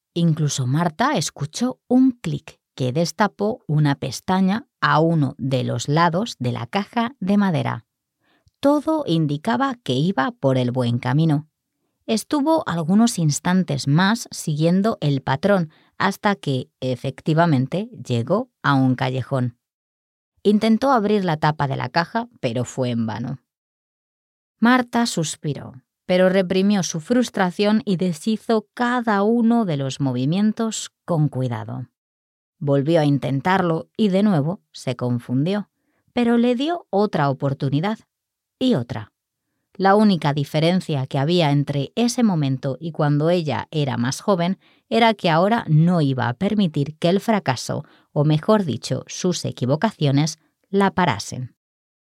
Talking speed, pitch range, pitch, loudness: 130 wpm, 140-205 Hz, 165 Hz, -21 LUFS